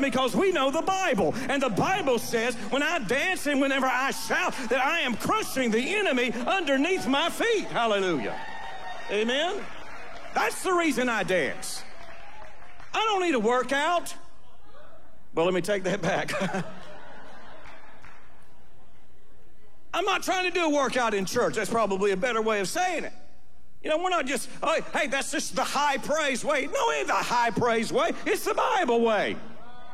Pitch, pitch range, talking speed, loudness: 265 Hz, 230-340 Hz, 170 wpm, -26 LUFS